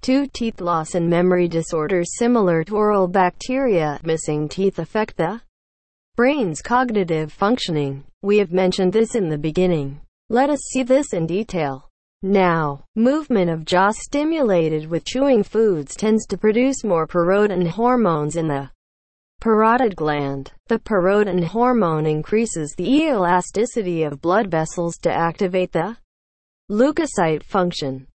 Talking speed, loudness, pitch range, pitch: 130 wpm, -19 LUFS, 160-225 Hz, 185 Hz